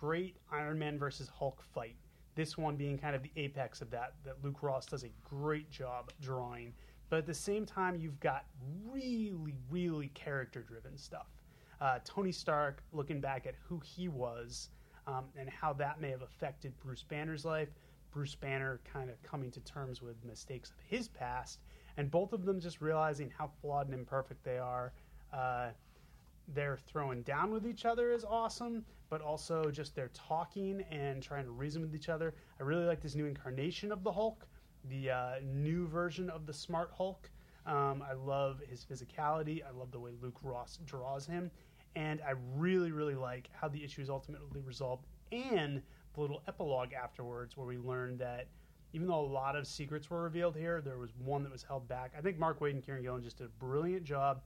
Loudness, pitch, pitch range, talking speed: -40 LUFS, 145 Hz, 130-160 Hz, 195 wpm